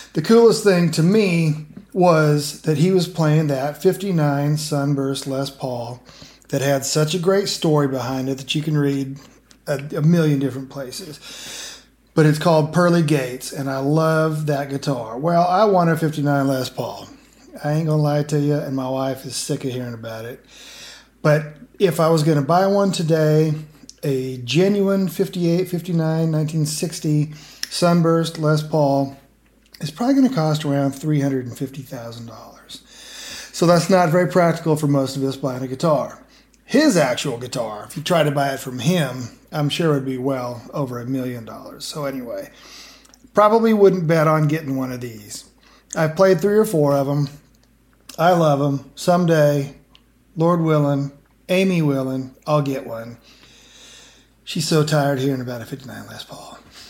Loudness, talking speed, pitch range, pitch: -19 LUFS, 165 wpm, 135-170 Hz, 150 Hz